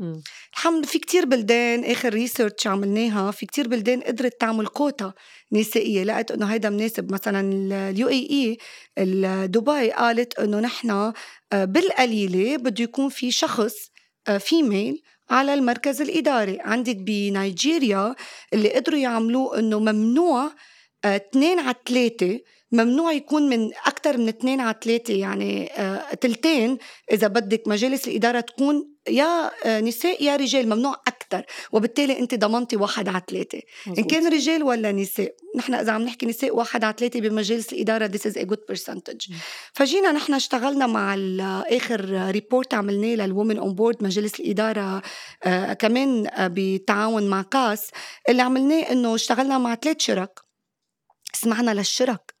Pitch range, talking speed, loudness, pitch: 210-265 Hz, 135 wpm, -22 LUFS, 230 Hz